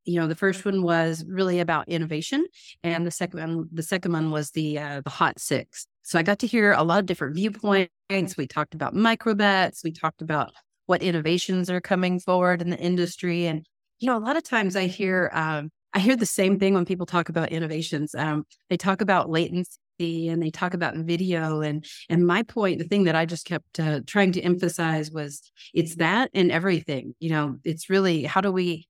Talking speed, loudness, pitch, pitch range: 215 wpm, -25 LUFS, 175 Hz, 160-190 Hz